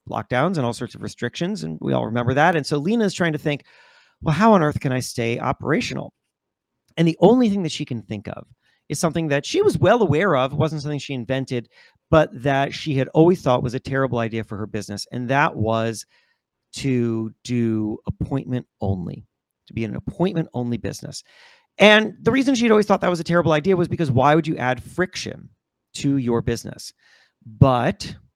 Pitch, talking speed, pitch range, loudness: 135 Hz, 205 wpm, 120-170 Hz, -21 LUFS